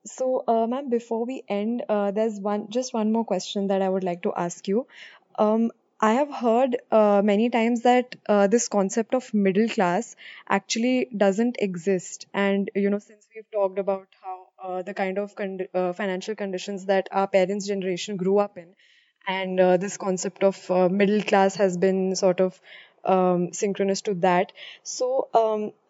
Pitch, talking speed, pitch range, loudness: 200 Hz, 180 wpm, 190-220 Hz, -24 LUFS